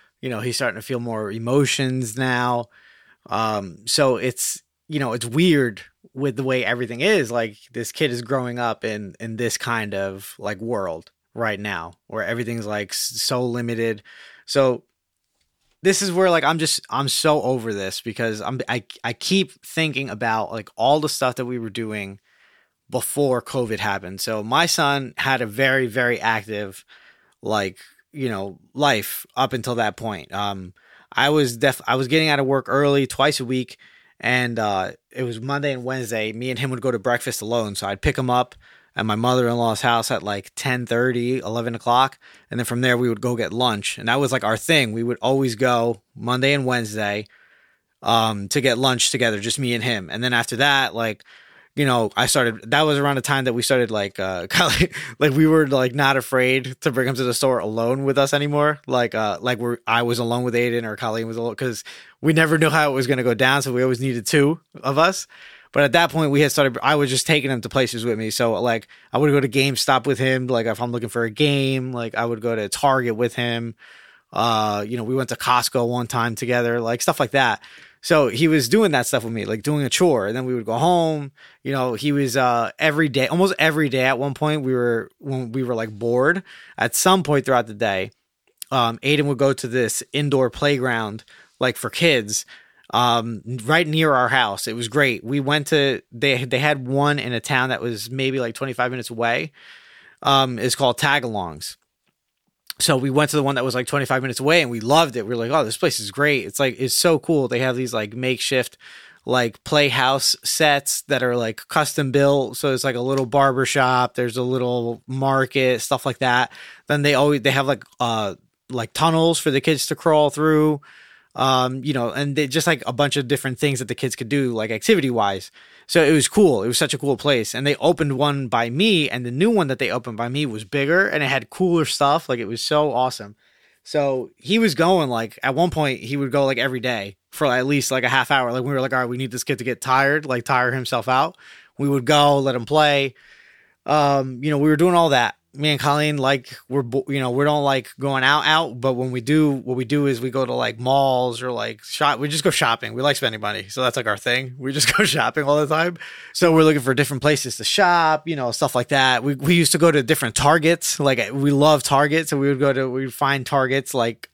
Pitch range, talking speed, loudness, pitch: 120-145 Hz, 230 wpm, -20 LUFS, 130 Hz